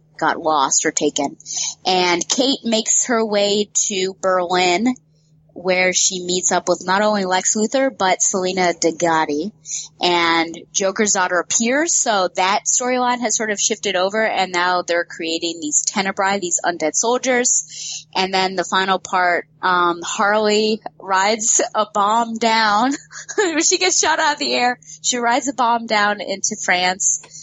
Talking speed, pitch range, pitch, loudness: 150 wpm, 170-220 Hz, 185 Hz, -17 LUFS